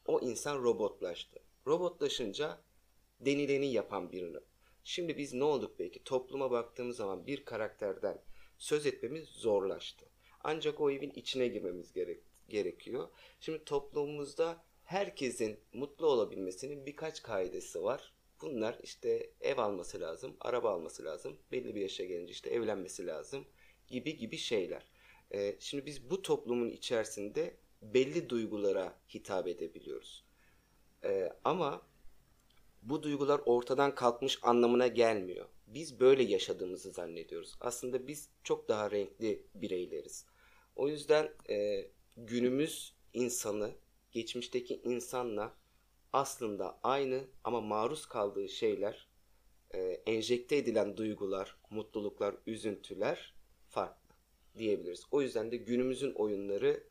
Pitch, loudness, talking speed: 155 Hz, -36 LUFS, 115 wpm